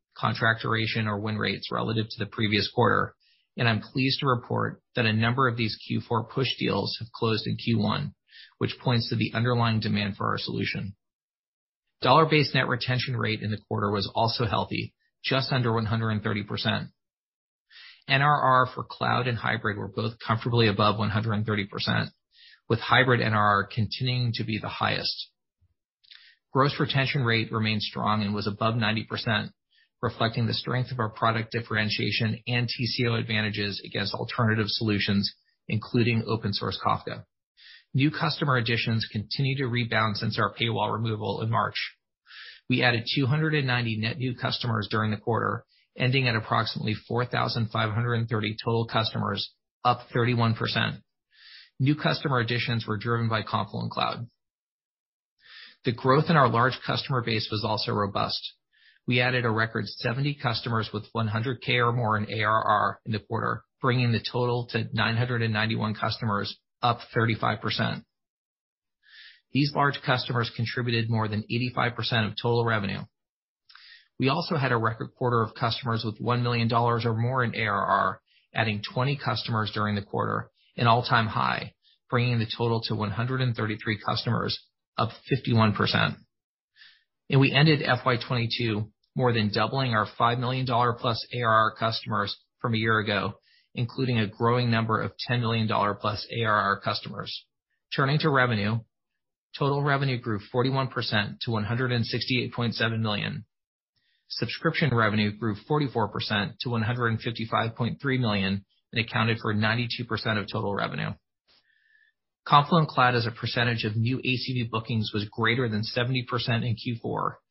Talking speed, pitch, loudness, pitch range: 140 wpm, 115 Hz, -26 LUFS, 110-125 Hz